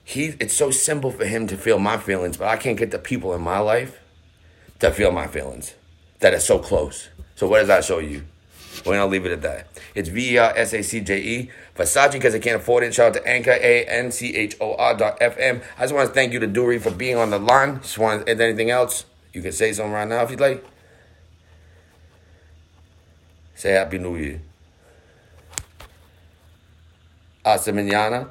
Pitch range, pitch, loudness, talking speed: 85-120 Hz, 105 Hz, -20 LUFS, 195 wpm